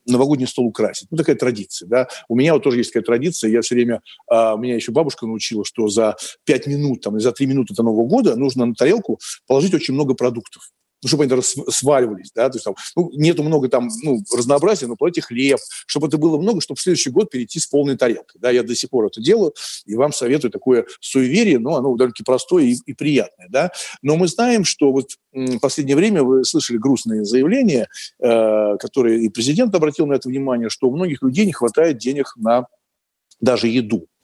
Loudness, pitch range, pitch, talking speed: -18 LUFS, 115-145 Hz, 130 Hz, 210 wpm